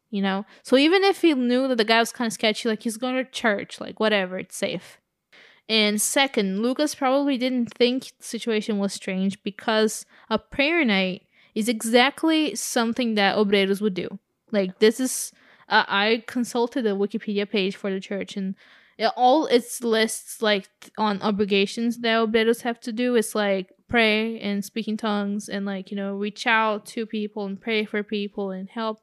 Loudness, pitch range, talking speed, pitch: -23 LUFS, 205-240 Hz, 185 wpm, 220 Hz